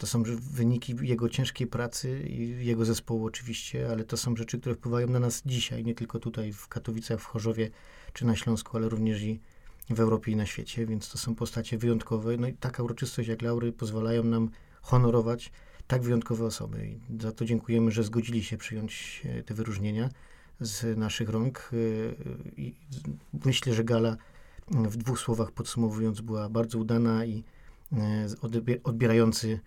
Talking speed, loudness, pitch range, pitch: 160 wpm, -30 LUFS, 110-120 Hz, 115 Hz